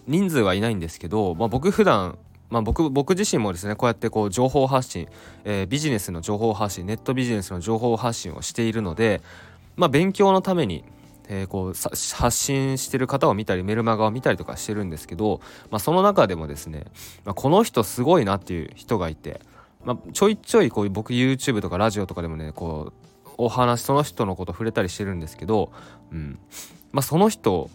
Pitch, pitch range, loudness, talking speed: 110 Hz, 90-130 Hz, -23 LUFS, 415 characters per minute